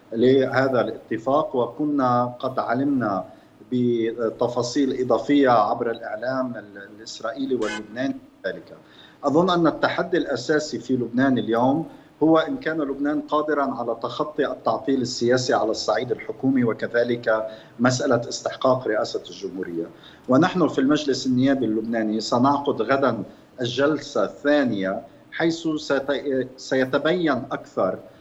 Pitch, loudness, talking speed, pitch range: 130 Hz, -23 LUFS, 100 wpm, 120-145 Hz